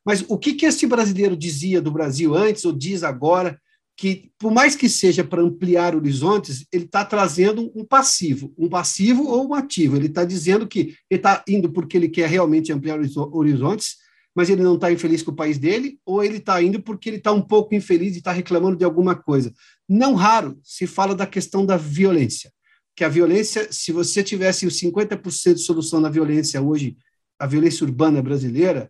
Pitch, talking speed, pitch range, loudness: 180 Hz, 190 wpm, 160-205 Hz, -19 LUFS